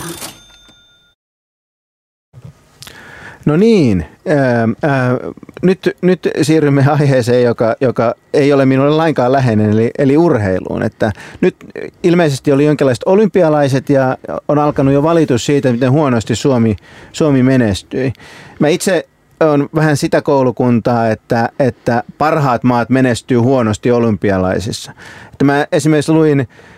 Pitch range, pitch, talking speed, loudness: 115-150 Hz, 135 Hz, 115 wpm, -13 LUFS